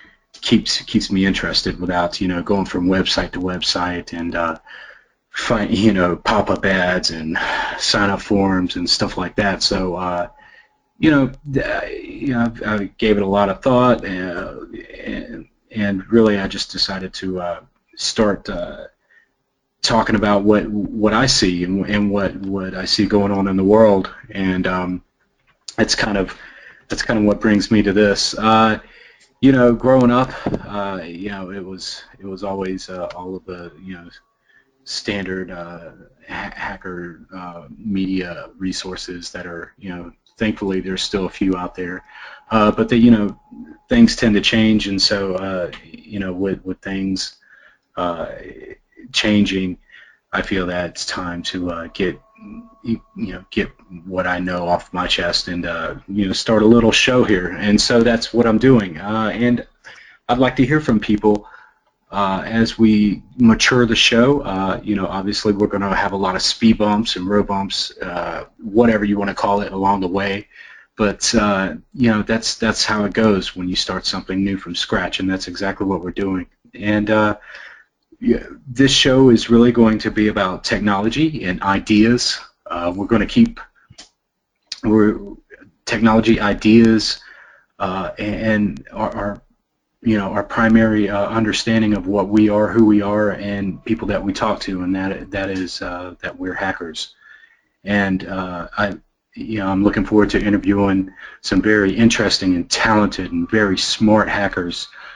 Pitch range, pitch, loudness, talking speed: 95-110 Hz, 100 Hz, -17 LUFS, 175 wpm